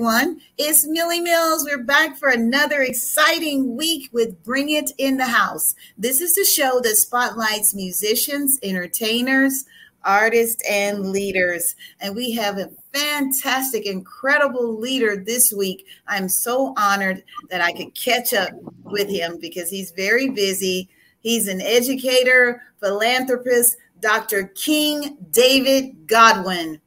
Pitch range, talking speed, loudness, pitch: 200-270 Hz, 125 wpm, -18 LUFS, 240 Hz